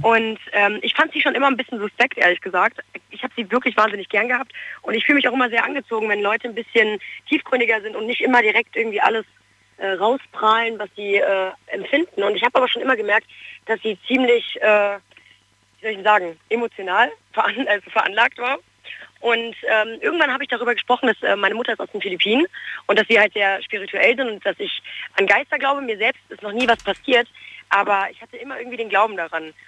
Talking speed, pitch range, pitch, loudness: 220 wpm, 210-250 Hz, 225 Hz, -19 LUFS